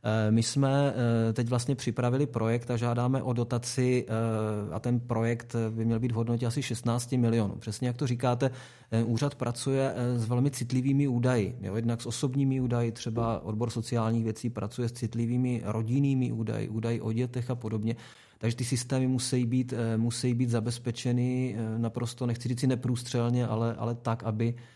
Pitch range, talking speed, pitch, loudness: 115-125 Hz, 160 wpm, 120 Hz, -30 LUFS